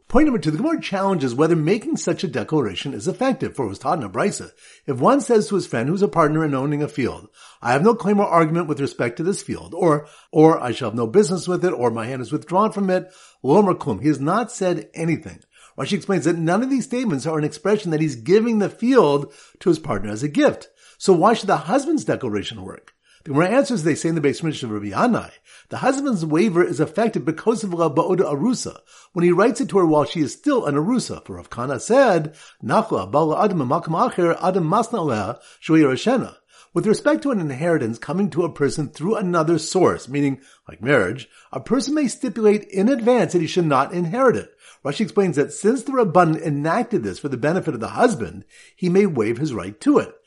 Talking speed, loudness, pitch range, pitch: 215 wpm, -20 LUFS, 150-210 Hz, 175 Hz